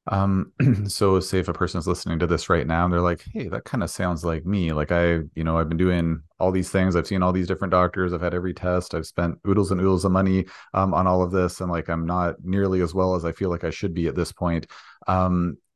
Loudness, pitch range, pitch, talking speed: -23 LUFS, 85-95 Hz, 90 Hz, 275 wpm